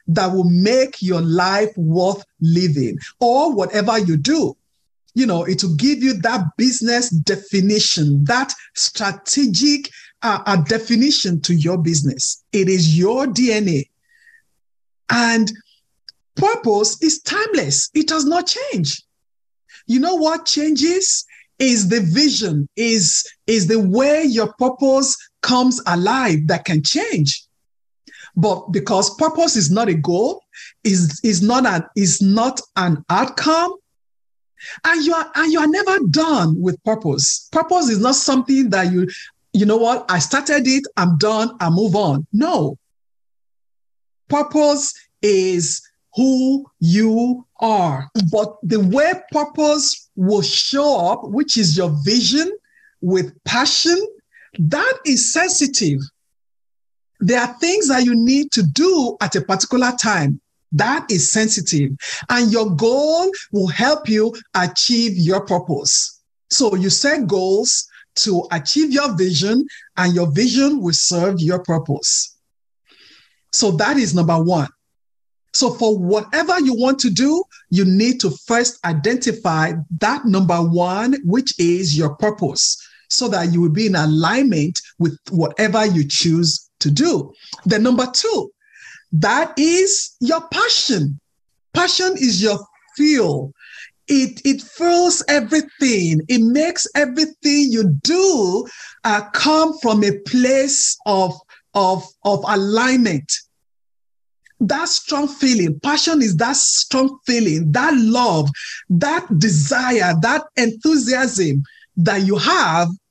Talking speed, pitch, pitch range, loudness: 130 wpm, 220 Hz, 180-280 Hz, -16 LUFS